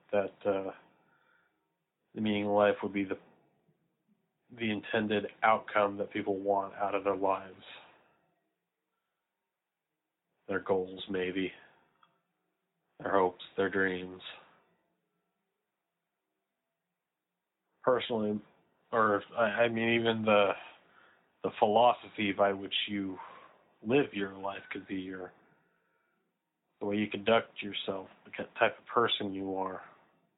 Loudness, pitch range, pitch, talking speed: -32 LUFS, 95-105 Hz, 100 Hz, 105 wpm